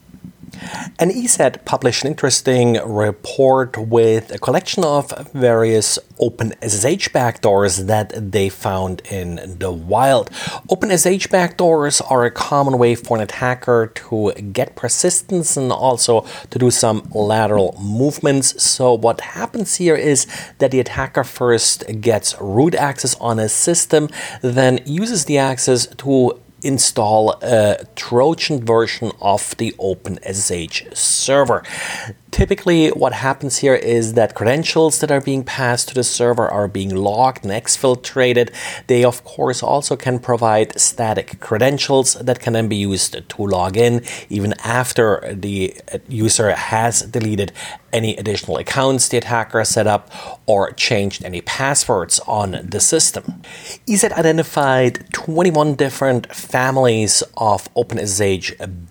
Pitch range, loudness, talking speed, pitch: 110-140 Hz, -16 LUFS, 130 wpm, 125 Hz